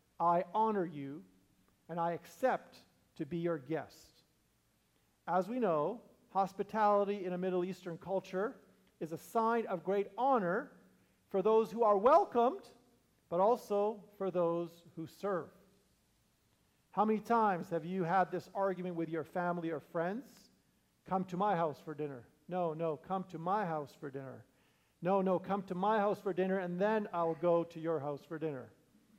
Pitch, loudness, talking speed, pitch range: 180 Hz, -35 LUFS, 165 wpm, 165-205 Hz